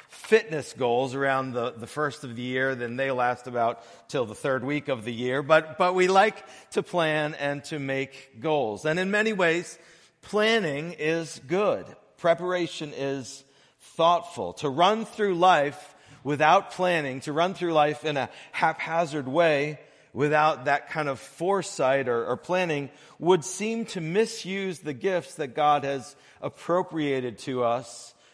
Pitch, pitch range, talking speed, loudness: 150 Hz, 135-175 Hz, 155 wpm, -26 LUFS